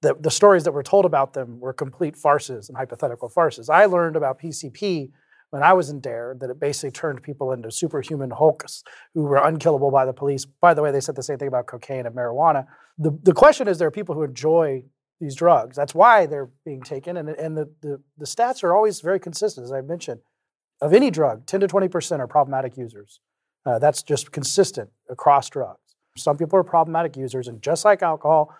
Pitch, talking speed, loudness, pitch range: 150 Hz, 215 wpm, -20 LUFS, 135-170 Hz